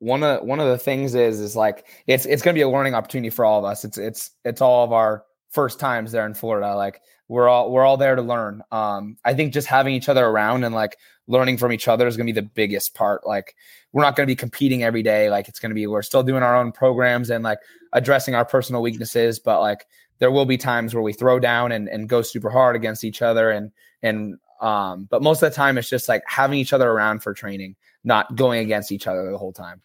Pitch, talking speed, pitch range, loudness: 120 Hz, 260 wpm, 110-130 Hz, -20 LUFS